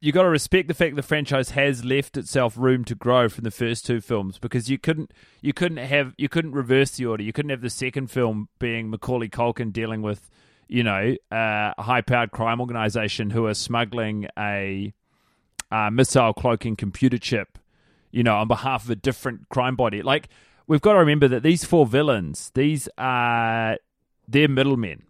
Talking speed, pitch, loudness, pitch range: 195 wpm, 125 Hz, -23 LUFS, 115-135 Hz